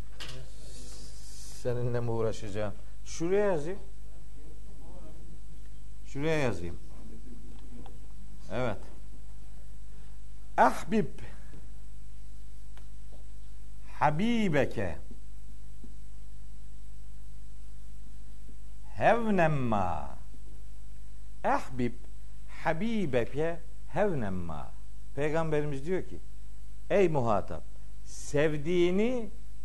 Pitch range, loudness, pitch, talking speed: 100-135 Hz, -31 LUFS, 120 Hz, 40 wpm